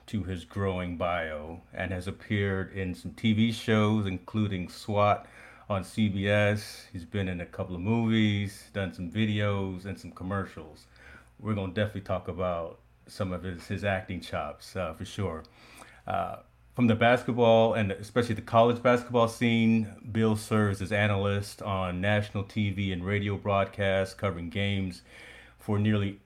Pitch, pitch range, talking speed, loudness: 100 Hz, 95-110 Hz, 150 wpm, -29 LUFS